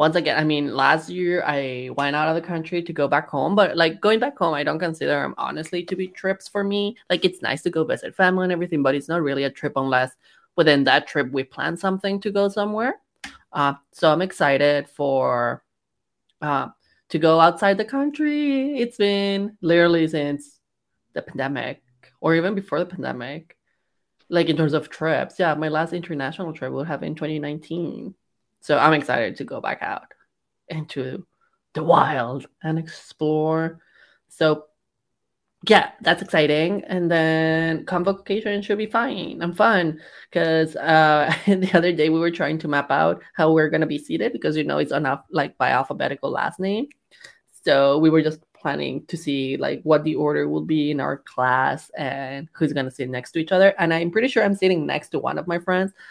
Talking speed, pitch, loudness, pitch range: 190 wpm, 160 Hz, -21 LUFS, 145-185 Hz